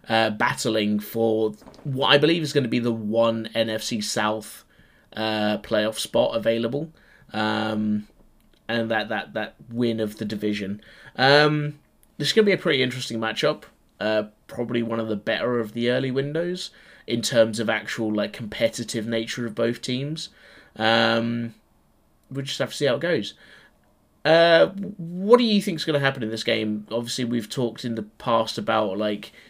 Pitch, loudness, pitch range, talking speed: 115 Hz, -23 LUFS, 110-140 Hz, 175 wpm